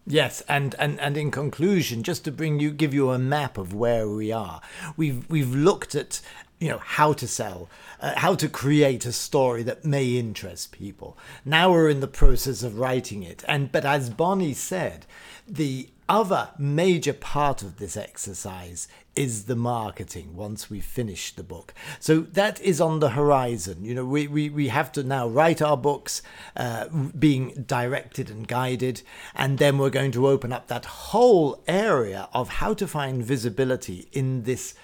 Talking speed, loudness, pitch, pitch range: 180 wpm, -24 LUFS, 135 Hz, 120-150 Hz